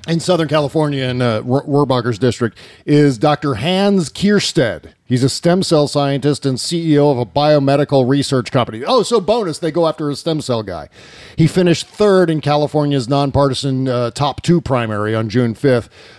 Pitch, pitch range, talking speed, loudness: 145 Hz, 130-160 Hz, 170 wpm, -15 LUFS